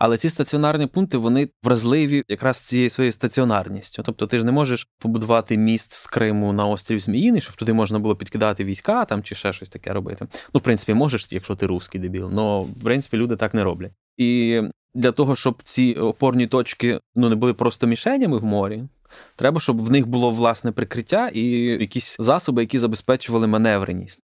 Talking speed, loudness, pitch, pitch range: 185 wpm, -21 LUFS, 115 Hz, 105-125 Hz